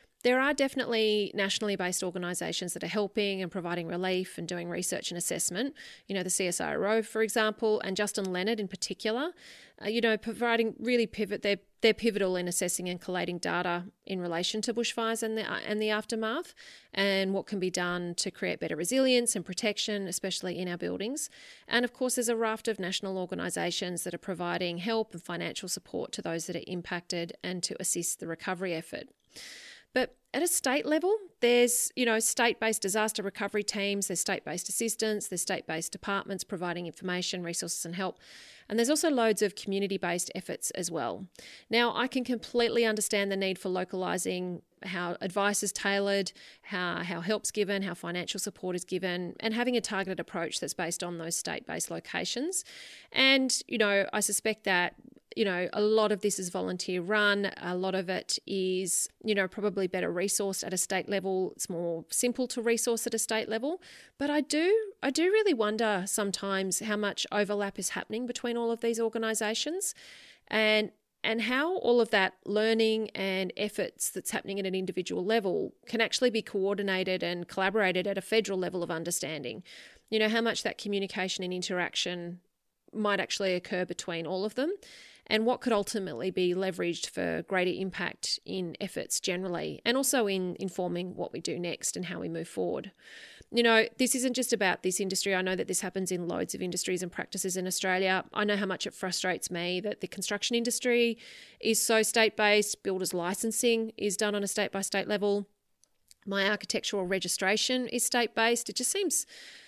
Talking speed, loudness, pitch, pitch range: 185 wpm, -30 LUFS, 200 Hz, 185-225 Hz